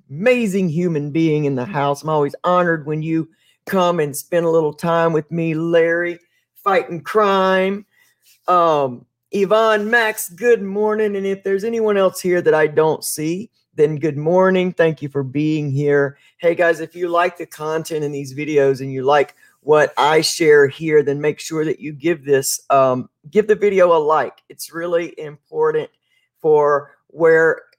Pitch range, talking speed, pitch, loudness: 150-185 Hz, 175 wpm, 165 Hz, -17 LUFS